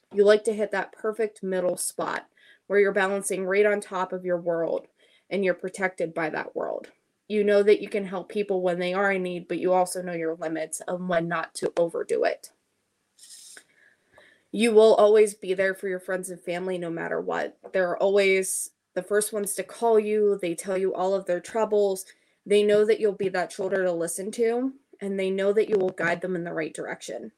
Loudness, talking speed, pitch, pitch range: -25 LUFS, 215 wpm, 190 Hz, 180-210 Hz